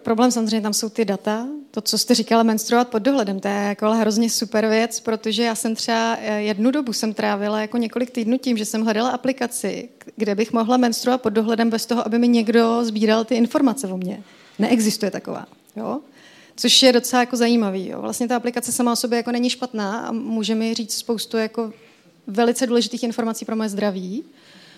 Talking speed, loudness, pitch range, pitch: 195 wpm, -20 LUFS, 220-240 Hz, 230 Hz